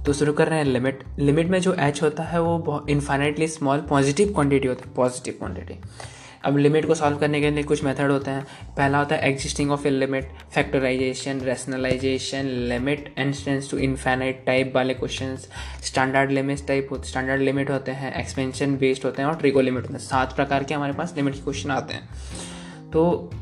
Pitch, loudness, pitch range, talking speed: 135 Hz, -23 LUFS, 130-145 Hz, 195 wpm